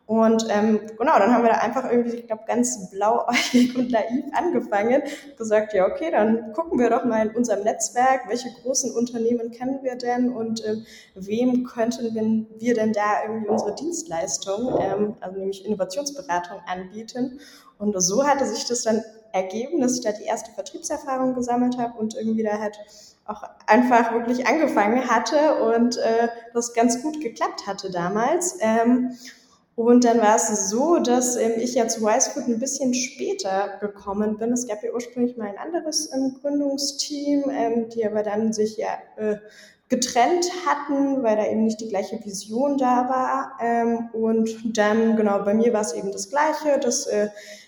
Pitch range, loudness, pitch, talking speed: 215-255 Hz, -23 LUFS, 230 Hz, 165 wpm